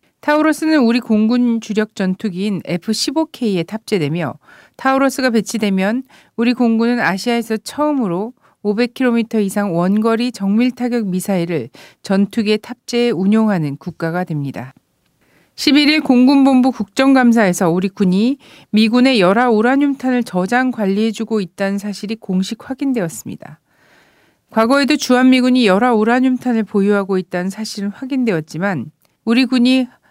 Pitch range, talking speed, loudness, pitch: 195-250 Hz, 320 characters per minute, -16 LUFS, 225 Hz